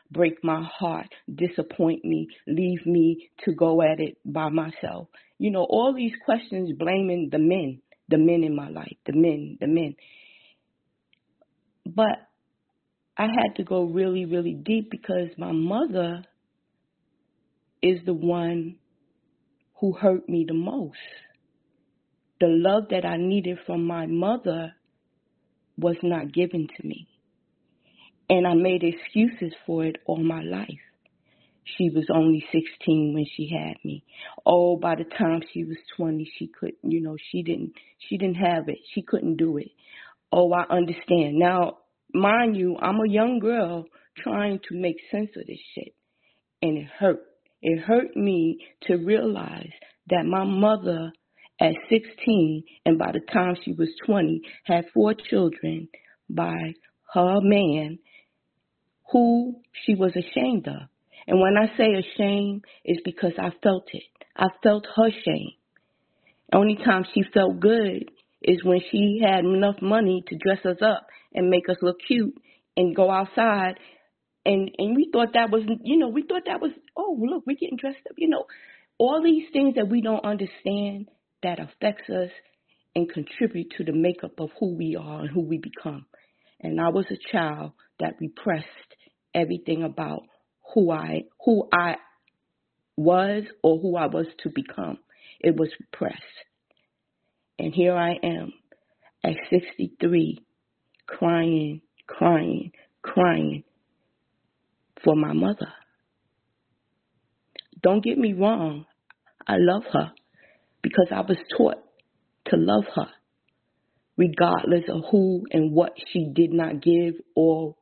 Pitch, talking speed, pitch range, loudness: 180 Hz, 145 wpm, 165-210 Hz, -24 LUFS